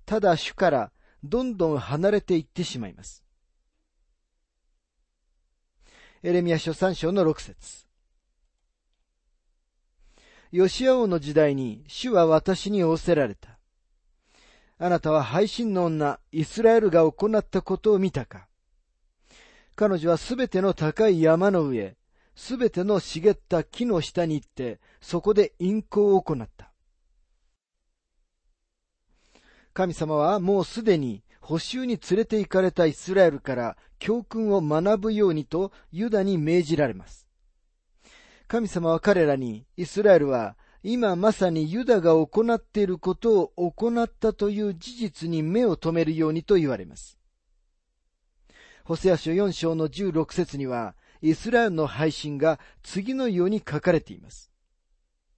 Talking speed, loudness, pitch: 245 characters per minute, -24 LUFS, 165 Hz